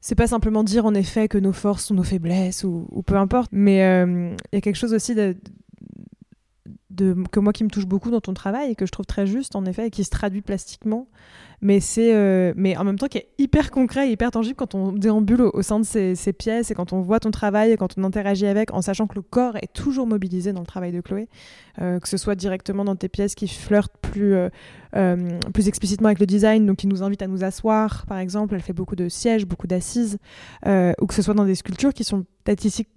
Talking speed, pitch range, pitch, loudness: 255 wpm, 190-215 Hz, 200 Hz, -21 LUFS